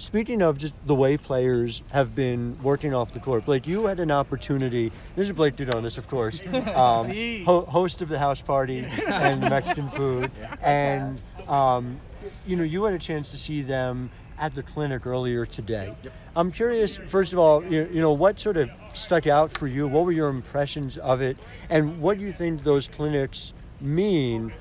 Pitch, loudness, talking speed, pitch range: 140 Hz, -25 LUFS, 190 wpm, 125-165 Hz